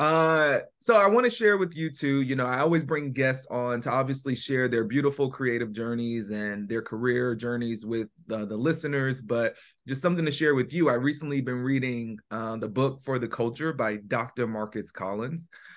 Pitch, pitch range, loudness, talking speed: 130 Hz, 115-145 Hz, -27 LUFS, 200 wpm